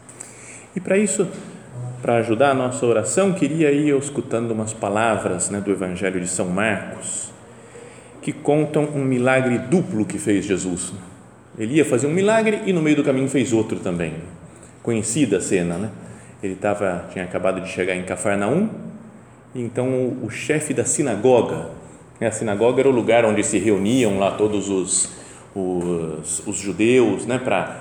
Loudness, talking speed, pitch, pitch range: -20 LUFS, 165 wpm, 115 Hz, 100-145 Hz